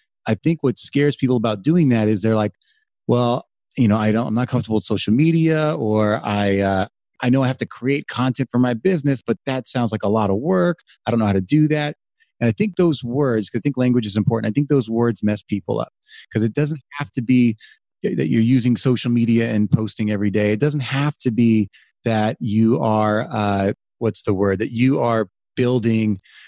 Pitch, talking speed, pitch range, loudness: 120 Hz, 225 wpm, 110-135 Hz, -20 LUFS